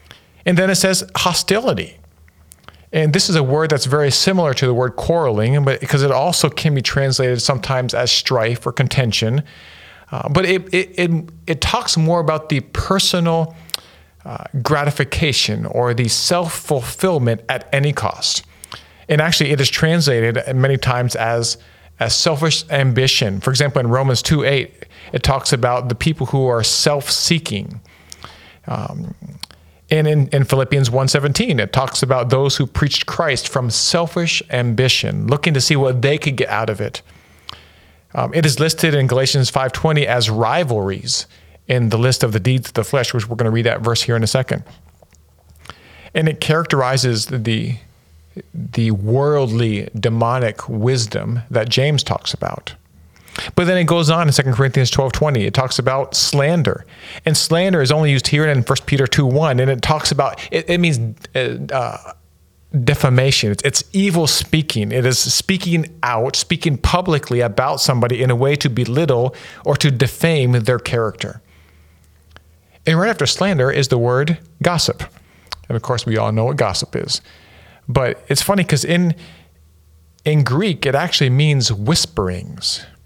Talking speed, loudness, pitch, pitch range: 160 wpm, -16 LUFS, 135 Hz, 115-155 Hz